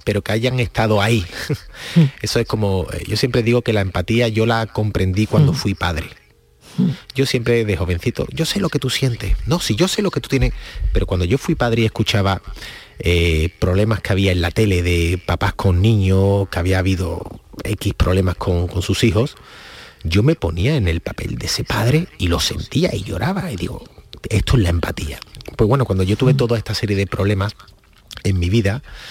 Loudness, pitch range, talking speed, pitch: -18 LUFS, 95-120 Hz, 200 wpm, 105 Hz